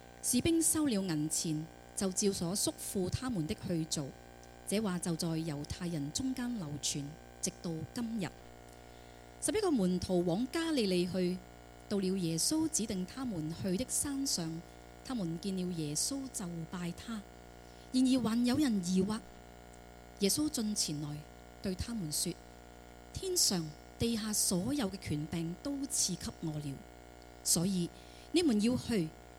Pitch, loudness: 170 Hz, -34 LUFS